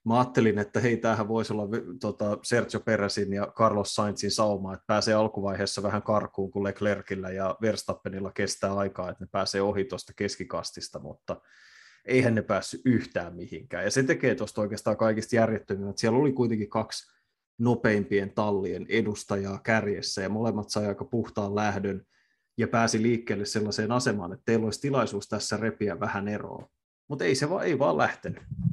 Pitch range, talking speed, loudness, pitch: 100-115 Hz, 165 wpm, -28 LUFS, 105 Hz